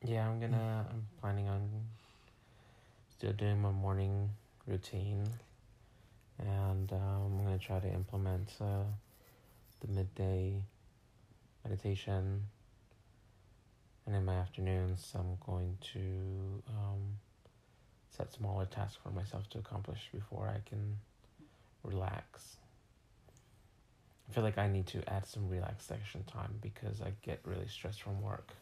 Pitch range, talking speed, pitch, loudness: 95-110 Hz, 120 wpm, 105 Hz, -40 LUFS